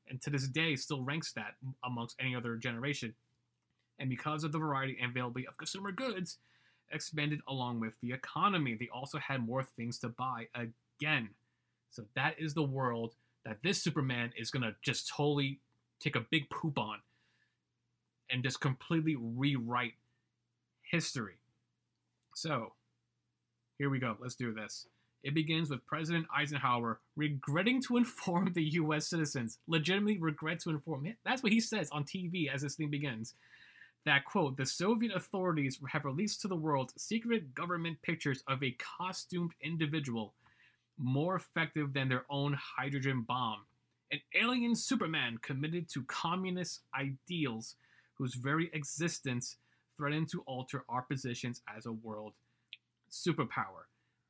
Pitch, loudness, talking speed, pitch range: 140 Hz, -36 LUFS, 145 wpm, 120-160 Hz